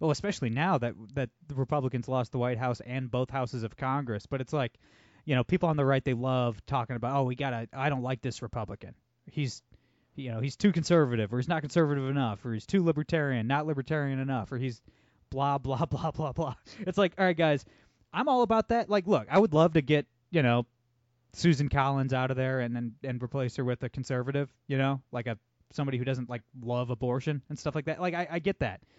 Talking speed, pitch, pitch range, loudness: 235 wpm, 135 Hz, 125-155 Hz, -30 LUFS